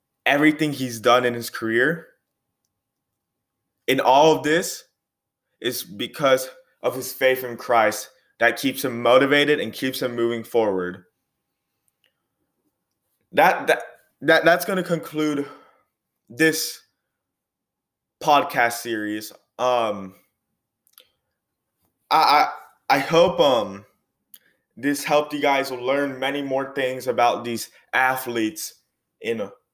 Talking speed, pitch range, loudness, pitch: 110 wpm, 120-150 Hz, -21 LUFS, 130 Hz